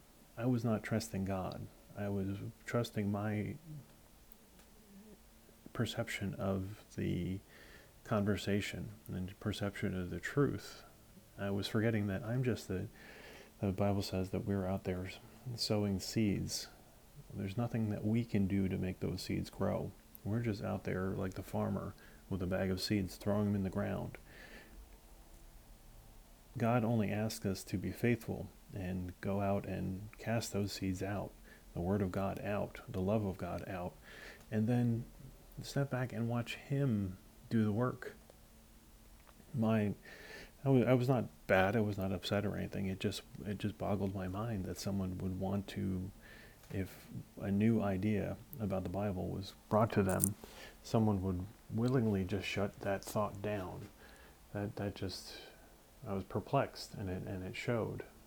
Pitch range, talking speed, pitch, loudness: 95-110 Hz, 155 wpm, 100 Hz, -38 LUFS